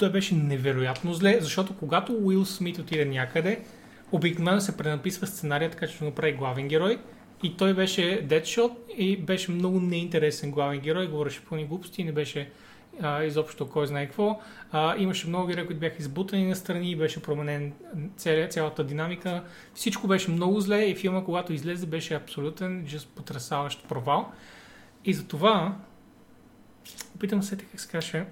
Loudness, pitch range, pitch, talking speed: -28 LUFS, 155-195 Hz, 175 Hz, 155 wpm